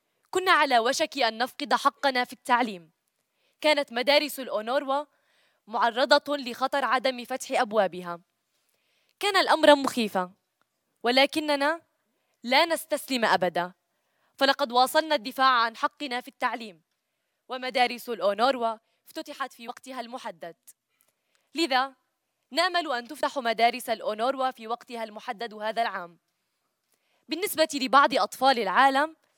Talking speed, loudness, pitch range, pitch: 105 wpm, -25 LUFS, 235-290 Hz, 260 Hz